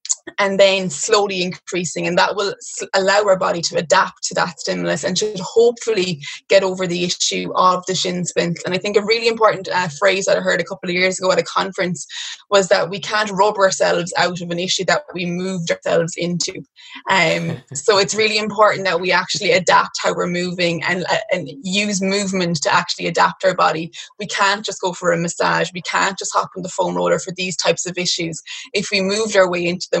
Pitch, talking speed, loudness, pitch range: 185 Hz, 220 wpm, -18 LUFS, 175-200 Hz